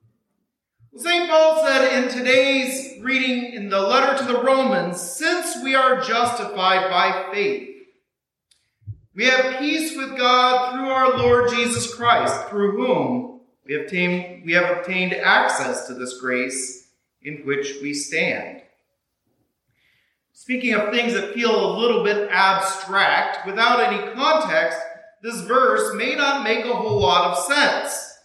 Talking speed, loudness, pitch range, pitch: 140 wpm, -19 LUFS, 180-265 Hz, 235 Hz